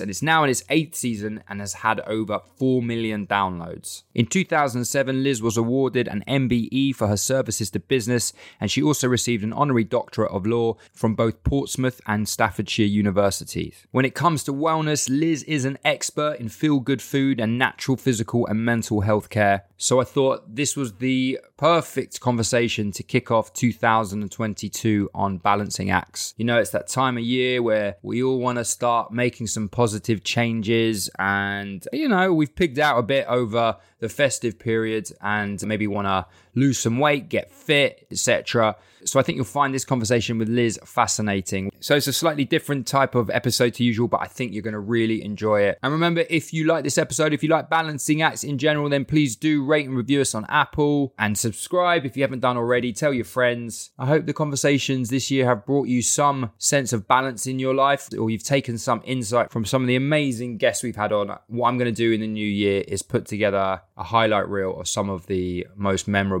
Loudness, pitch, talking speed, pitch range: -22 LUFS, 120 Hz, 205 wpm, 105-135 Hz